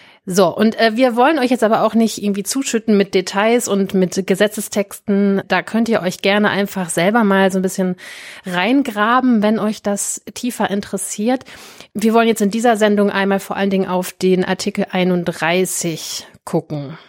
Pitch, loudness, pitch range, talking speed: 200 Hz, -16 LUFS, 190-225 Hz, 170 wpm